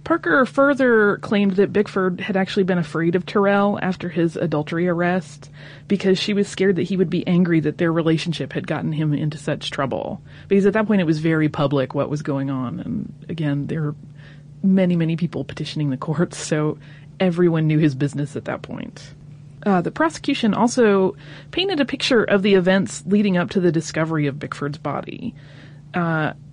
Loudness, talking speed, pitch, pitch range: -20 LUFS, 185 wpm, 170 Hz, 150-195 Hz